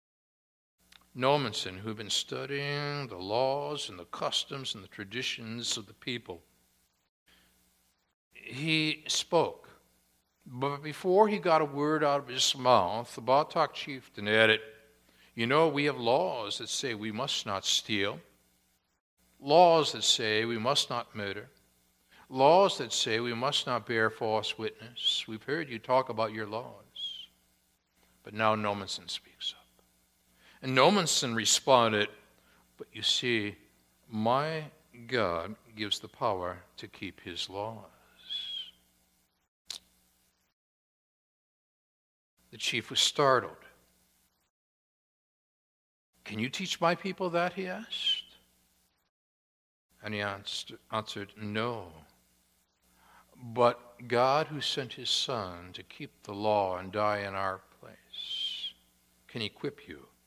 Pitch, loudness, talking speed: 110 Hz, -30 LUFS, 120 wpm